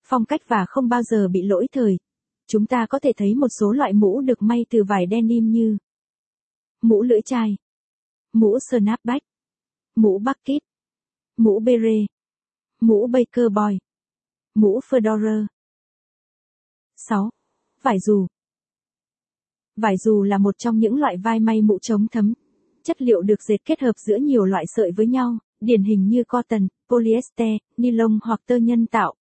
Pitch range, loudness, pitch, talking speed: 210-245 Hz, -20 LUFS, 225 Hz, 155 wpm